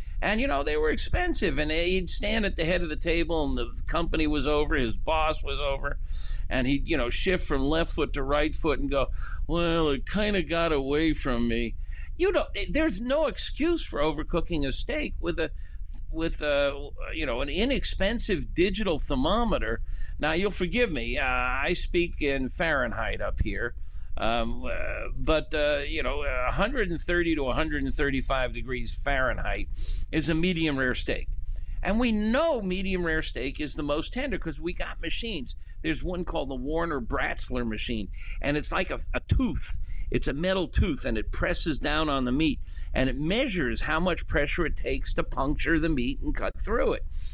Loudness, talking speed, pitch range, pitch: -28 LUFS, 180 wpm, 130-180 Hz, 155 Hz